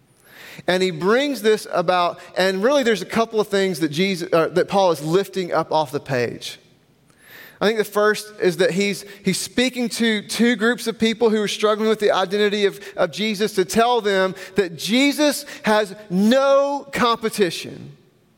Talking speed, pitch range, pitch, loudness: 175 wpm, 185-225 Hz, 200 Hz, -20 LUFS